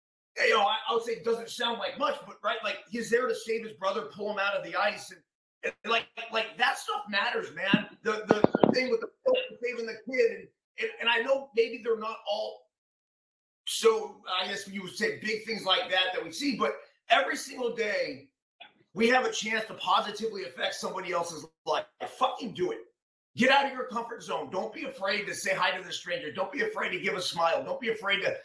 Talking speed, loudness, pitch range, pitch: 230 wpm, -29 LUFS, 200-275 Hz, 230 Hz